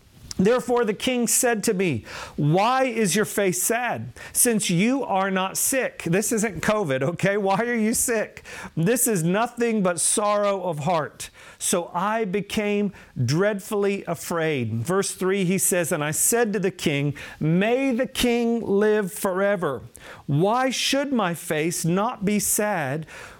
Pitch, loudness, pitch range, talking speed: 200 Hz, -23 LUFS, 175-230 Hz, 150 wpm